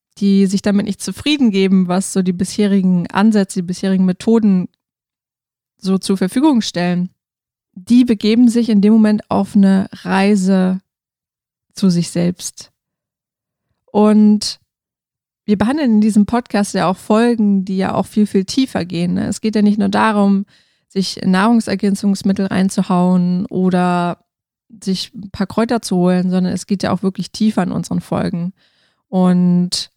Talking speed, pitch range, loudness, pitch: 145 wpm, 185-215 Hz, -15 LUFS, 195 Hz